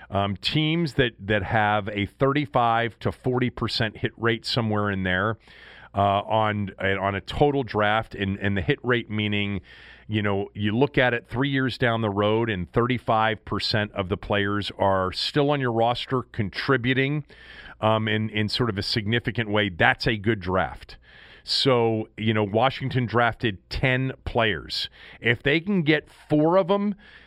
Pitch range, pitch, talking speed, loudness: 105-125 Hz, 115 Hz, 170 wpm, -24 LUFS